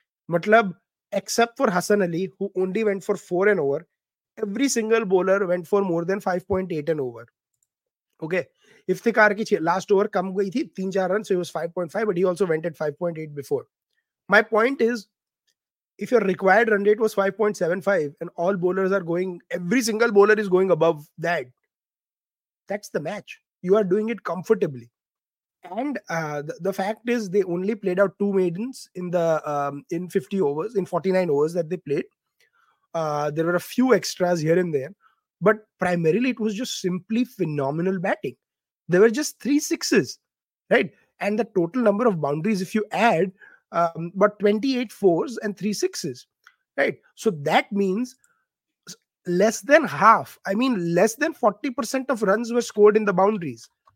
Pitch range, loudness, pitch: 175-220 Hz, -23 LUFS, 195 Hz